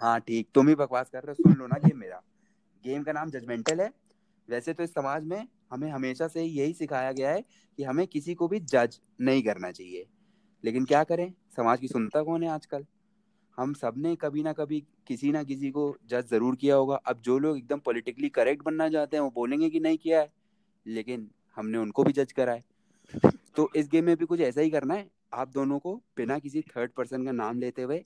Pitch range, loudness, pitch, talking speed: 130-180 Hz, -28 LUFS, 150 Hz, 225 wpm